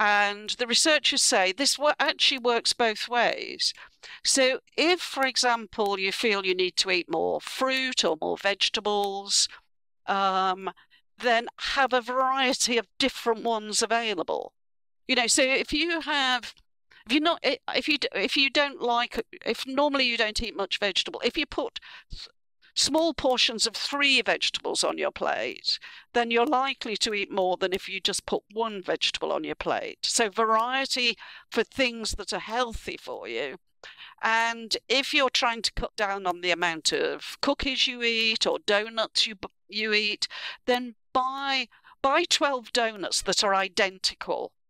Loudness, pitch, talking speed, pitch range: -25 LUFS, 240 Hz, 160 wpm, 210-275 Hz